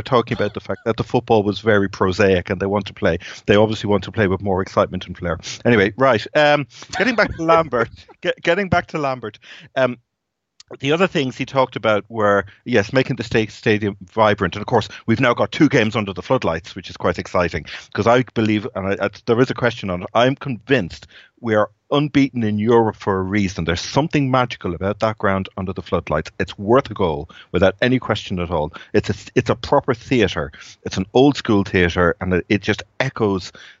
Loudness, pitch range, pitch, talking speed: -19 LUFS, 100-130 Hz, 110 Hz, 215 wpm